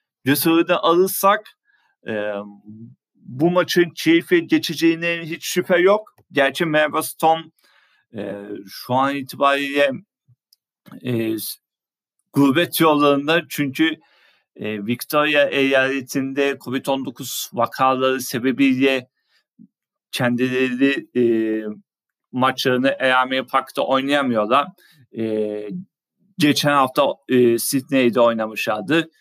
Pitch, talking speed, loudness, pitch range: 135 Hz, 80 wpm, -19 LUFS, 125-165 Hz